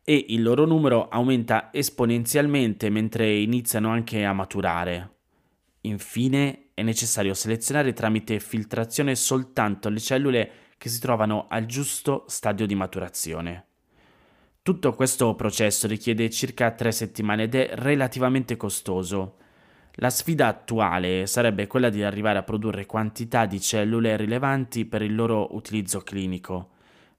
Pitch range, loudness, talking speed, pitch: 105-125 Hz, -24 LUFS, 125 wpm, 110 Hz